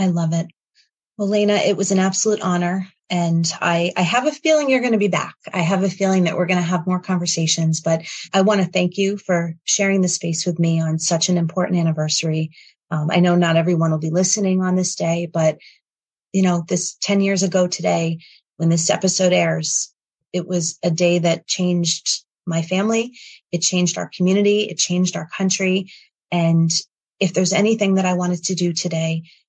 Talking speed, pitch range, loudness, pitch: 200 wpm, 165-190 Hz, -19 LUFS, 180 Hz